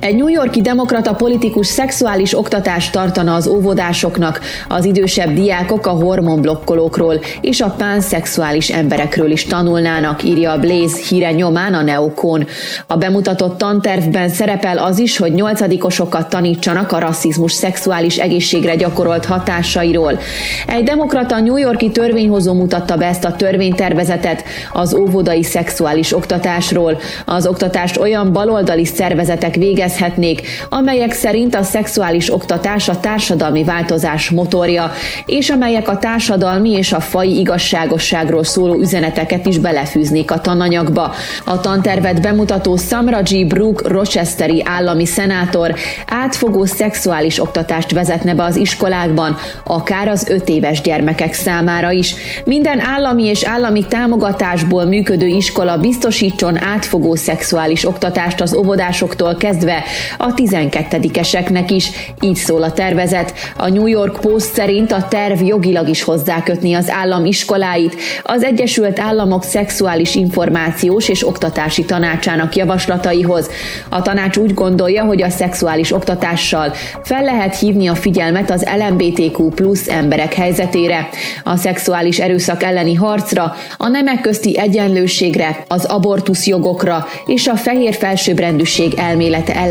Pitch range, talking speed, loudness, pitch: 170-200 Hz, 125 wpm, -14 LUFS, 180 Hz